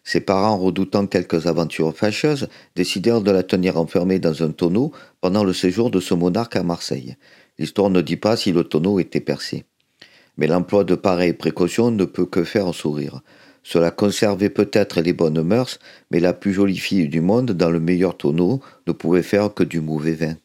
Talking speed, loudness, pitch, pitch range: 195 wpm, -20 LUFS, 90 Hz, 85-100 Hz